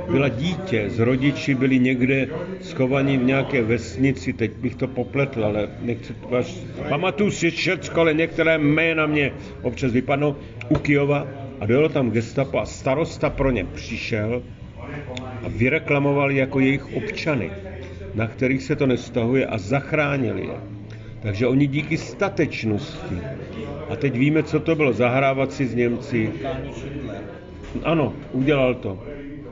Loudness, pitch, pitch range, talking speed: -22 LUFS, 130 Hz, 120-145 Hz, 140 wpm